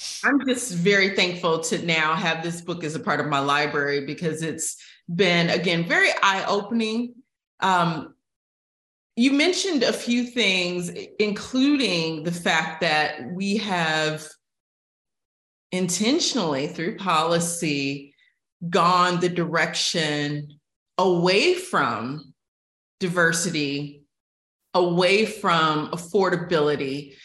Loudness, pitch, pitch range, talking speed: -22 LUFS, 175 Hz, 155-200 Hz, 100 wpm